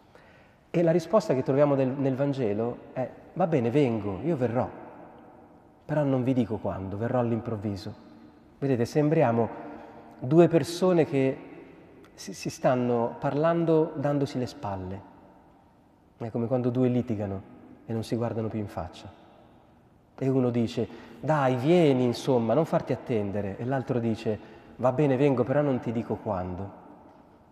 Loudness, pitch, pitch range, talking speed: -27 LUFS, 125 Hz, 110-140 Hz, 140 wpm